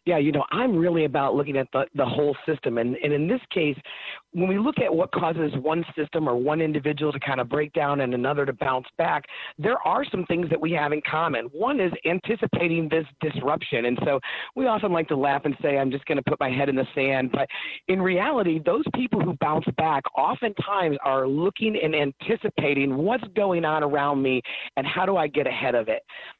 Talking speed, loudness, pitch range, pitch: 220 wpm, -24 LUFS, 140-180 Hz, 155 Hz